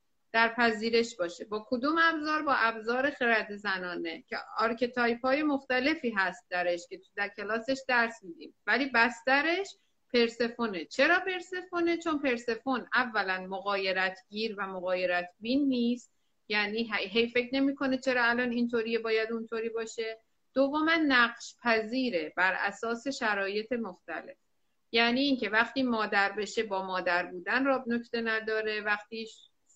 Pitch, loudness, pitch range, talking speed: 230 Hz, -29 LUFS, 205-255 Hz, 135 wpm